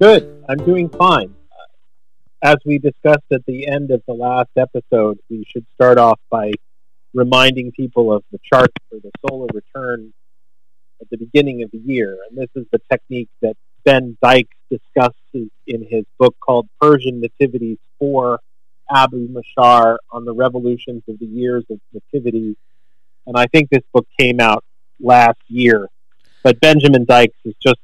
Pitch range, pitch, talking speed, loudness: 115-130 Hz, 125 Hz, 160 wpm, -14 LUFS